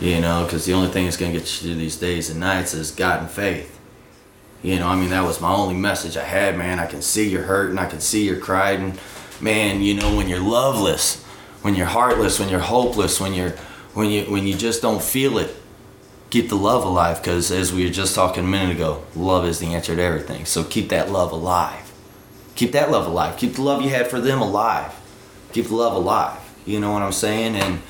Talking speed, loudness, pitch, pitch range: 235 wpm, -20 LUFS, 95 Hz, 85-105 Hz